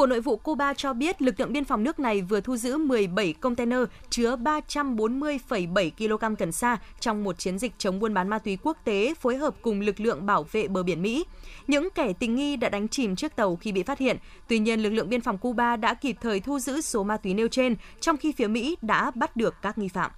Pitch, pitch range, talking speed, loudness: 235 Hz, 210-275 Hz, 245 wpm, -27 LUFS